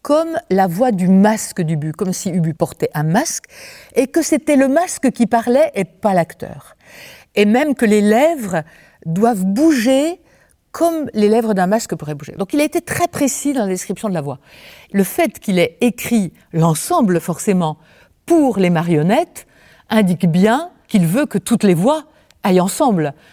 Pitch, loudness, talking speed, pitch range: 215 Hz, -16 LUFS, 175 wpm, 180-275 Hz